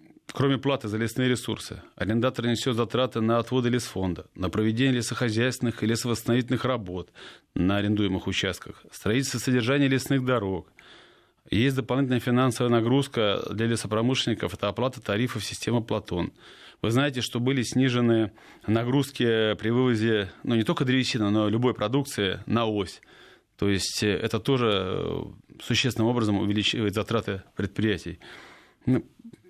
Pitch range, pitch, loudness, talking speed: 105-130 Hz, 115 Hz, -26 LUFS, 125 wpm